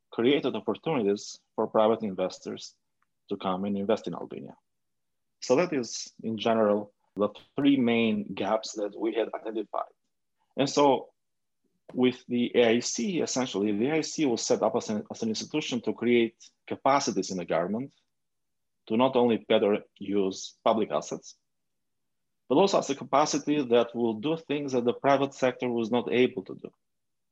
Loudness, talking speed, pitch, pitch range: -27 LUFS, 155 wpm, 120 Hz, 110-135 Hz